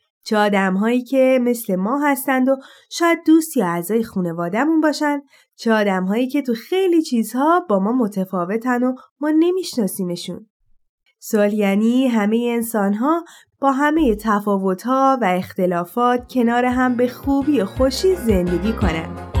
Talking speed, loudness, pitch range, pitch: 140 wpm, -19 LUFS, 205-275 Hz, 240 Hz